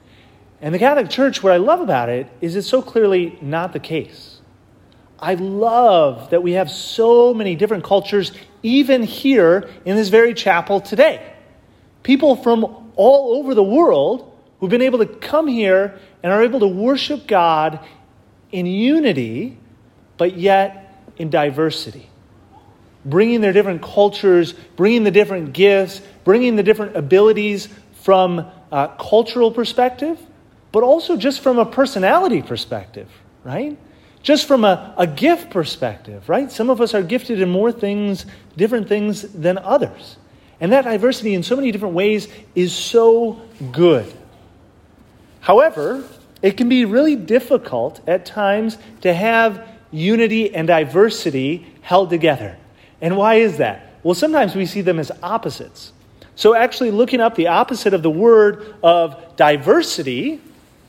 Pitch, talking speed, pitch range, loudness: 200 Hz, 145 wpm, 170-235 Hz, -16 LUFS